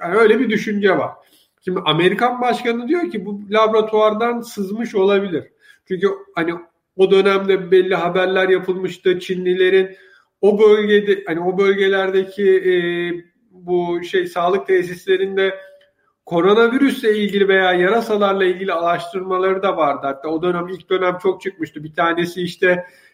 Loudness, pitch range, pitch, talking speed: -17 LUFS, 180-205 Hz, 190 Hz, 130 wpm